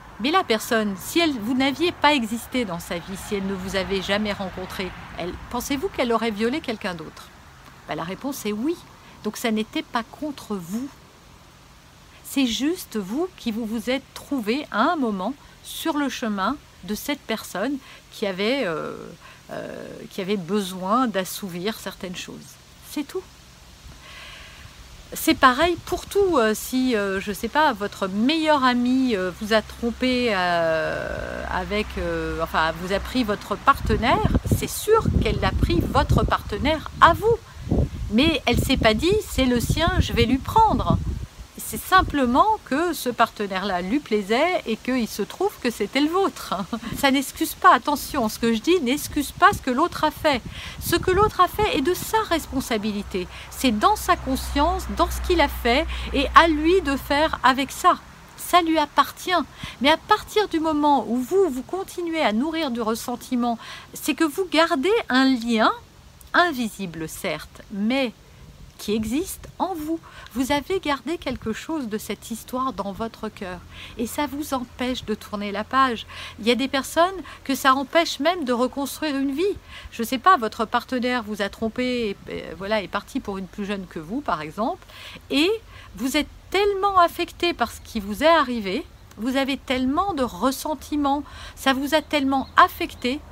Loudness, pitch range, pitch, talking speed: -23 LUFS, 220-310 Hz, 260 Hz, 175 wpm